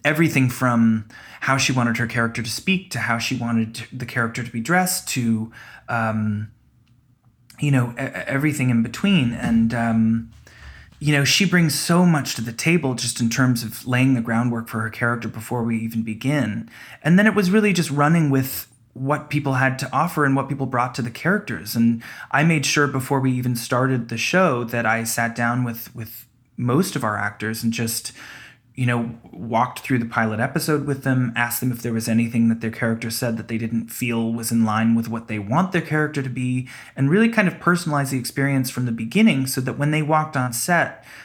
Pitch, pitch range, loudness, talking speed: 125 Hz, 115-140 Hz, -21 LUFS, 210 wpm